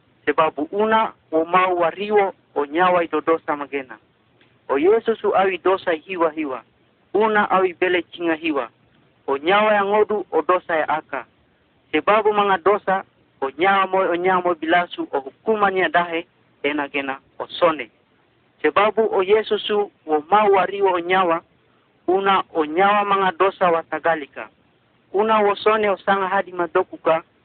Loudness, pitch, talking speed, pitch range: -20 LUFS, 180 Hz, 125 wpm, 160-200 Hz